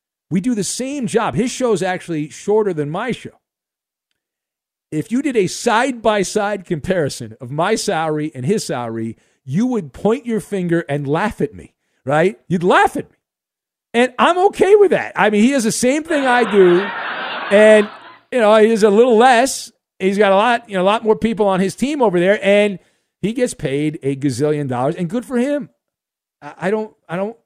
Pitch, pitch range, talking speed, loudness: 205 Hz, 170-230 Hz, 205 wpm, -16 LUFS